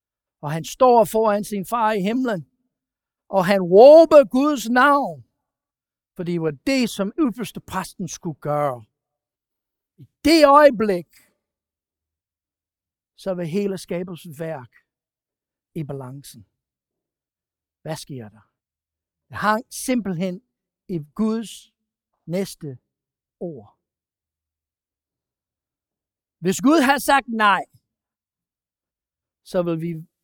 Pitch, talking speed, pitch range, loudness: 180 Hz, 100 wpm, 135-220 Hz, -19 LUFS